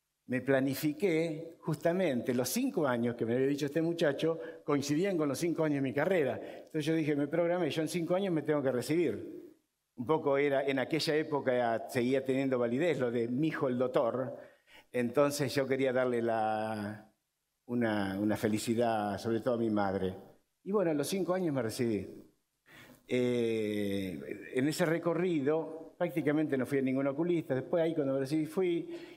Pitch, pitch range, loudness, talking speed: 140 Hz, 120-160 Hz, -32 LUFS, 175 wpm